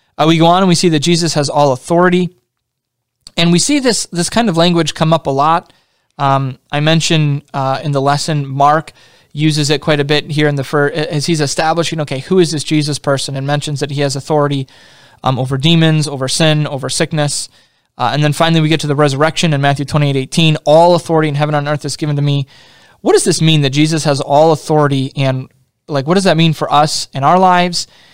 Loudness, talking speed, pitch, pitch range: -13 LUFS, 230 wpm, 150 Hz, 140-165 Hz